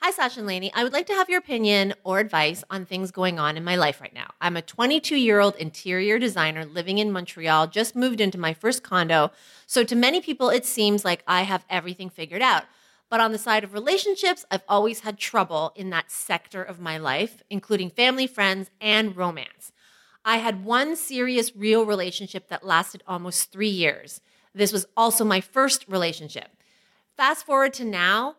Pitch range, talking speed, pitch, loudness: 180-230 Hz, 195 wpm, 200 Hz, -23 LUFS